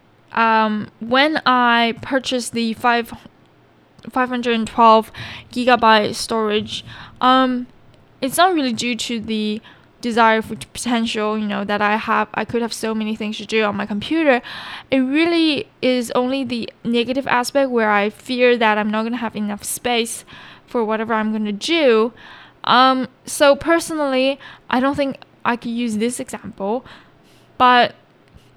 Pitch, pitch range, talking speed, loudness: 235 Hz, 220-255 Hz, 150 wpm, -18 LUFS